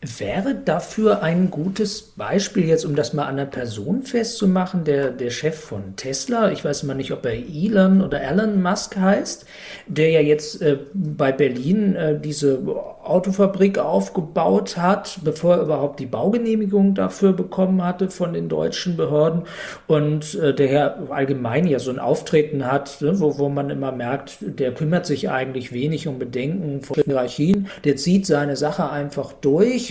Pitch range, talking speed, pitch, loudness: 140-190 Hz, 170 wpm, 155 Hz, -21 LUFS